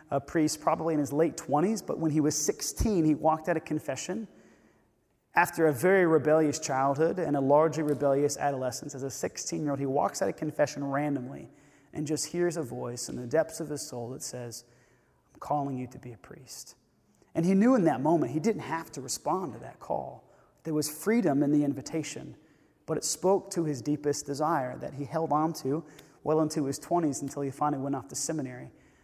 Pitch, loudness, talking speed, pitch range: 150 Hz, -29 LUFS, 210 wpm, 140-160 Hz